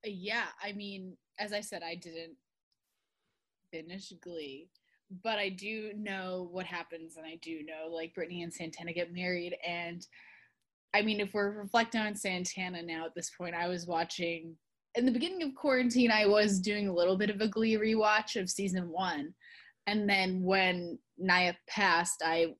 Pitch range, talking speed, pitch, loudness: 170-210 Hz, 175 wpm, 185 Hz, -32 LUFS